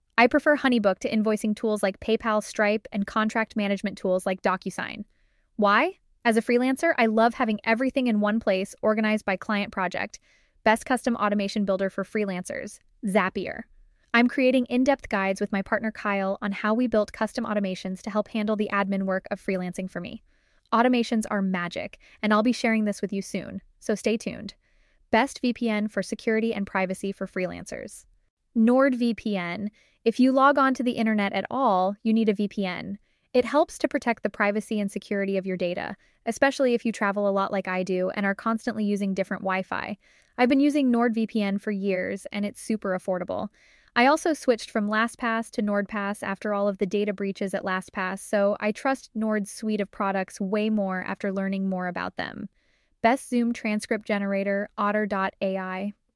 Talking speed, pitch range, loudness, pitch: 180 wpm, 195-230 Hz, -26 LUFS, 210 Hz